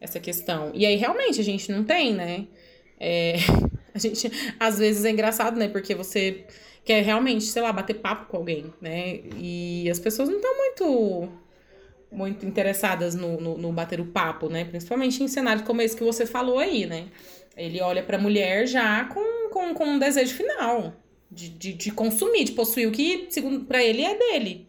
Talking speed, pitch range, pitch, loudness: 190 wpm, 180-240 Hz, 215 Hz, -25 LUFS